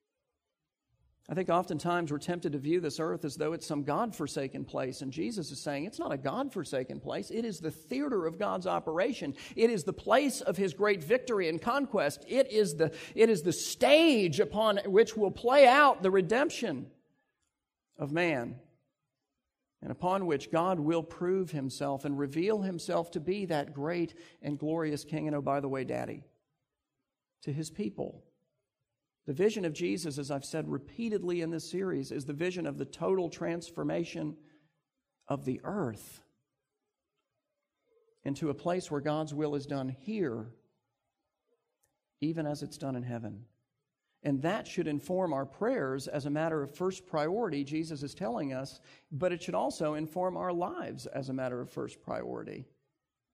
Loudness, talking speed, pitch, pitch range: -32 LUFS, 170 wpm, 165 Hz, 145-190 Hz